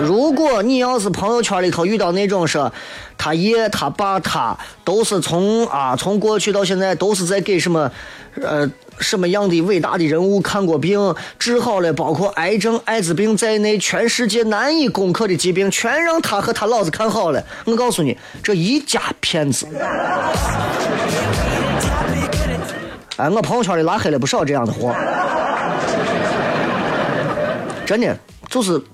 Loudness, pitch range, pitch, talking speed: -18 LUFS, 175-225 Hz, 200 Hz, 230 characters per minute